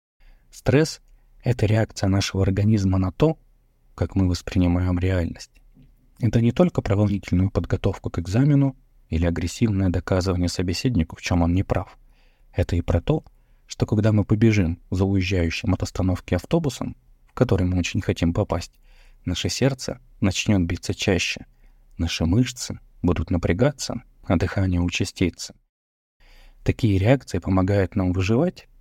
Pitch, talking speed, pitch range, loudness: 95 Hz, 130 wpm, 90-110 Hz, -23 LUFS